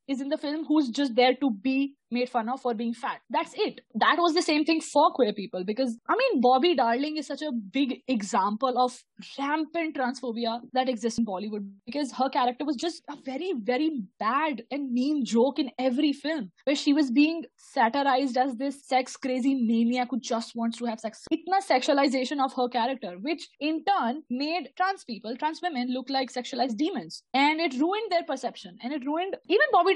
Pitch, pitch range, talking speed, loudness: 265 Hz, 245-305 Hz, 200 wpm, -27 LUFS